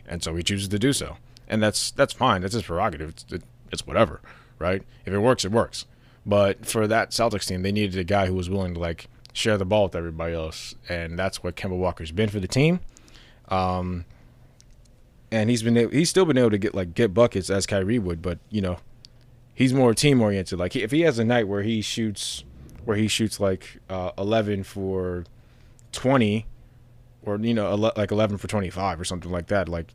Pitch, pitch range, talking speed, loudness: 105 Hz, 95-120 Hz, 215 wpm, -24 LUFS